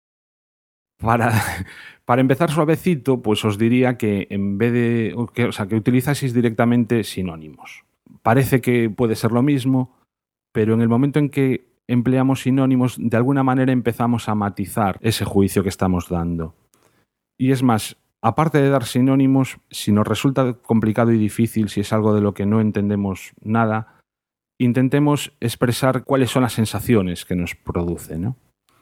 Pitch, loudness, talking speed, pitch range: 115 Hz, -19 LUFS, 155 wpm, 105-130 Hz